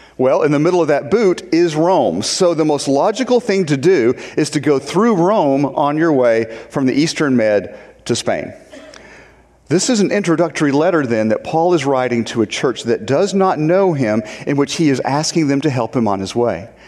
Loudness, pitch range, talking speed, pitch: -15 LUFS, 130-180 Hz, 215 wpm, 150 Hz